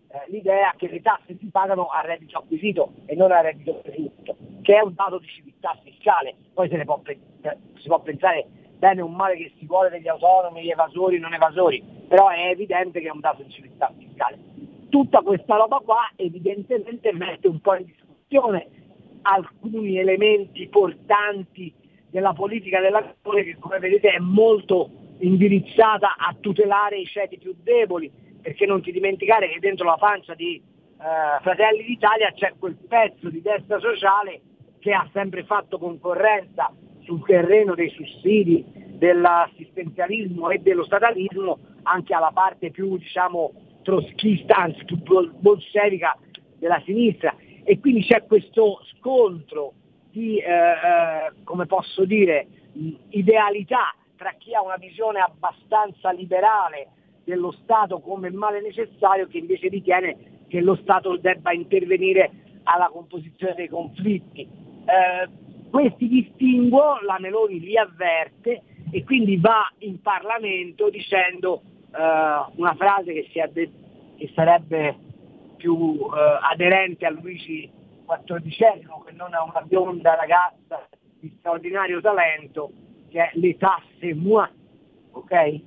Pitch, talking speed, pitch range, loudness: 190 Hz, 135 wpm, 170-210 Hz, -21 LUFS